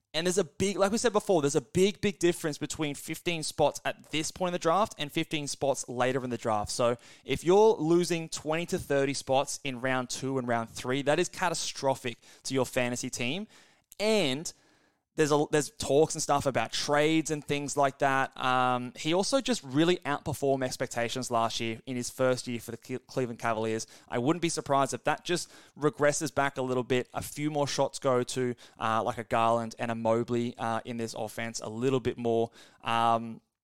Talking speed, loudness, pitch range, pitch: 205 wpm, -29 LUFS, 120-155 Hz, 135 Hz